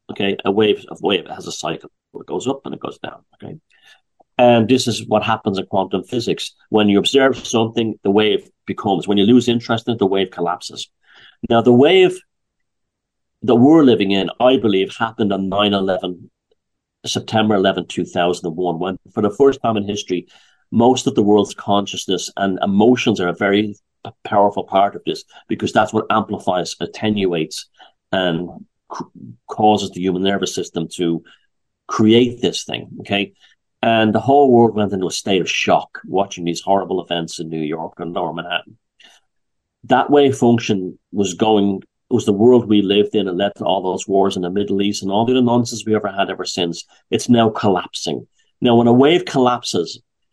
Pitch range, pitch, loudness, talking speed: 95-115 Hz, 105 Hz, -17 LUFS, 180 wpm